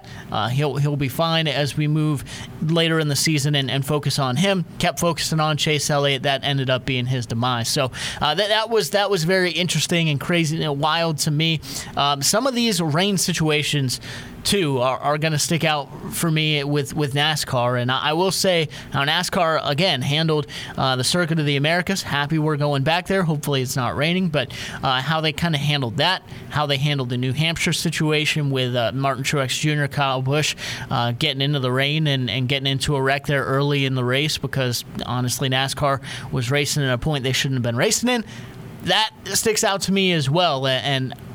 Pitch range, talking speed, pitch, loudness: 135-160 Hz, 210 wpm, 145 Hz, -20 LUFS